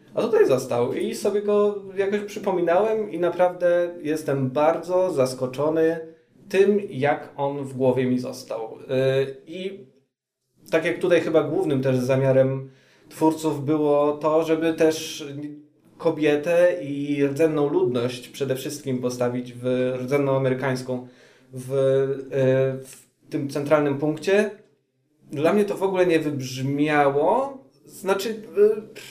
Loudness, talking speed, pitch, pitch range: -23 LUFS, 120 wpm, 150 Hz, 135-170 Hz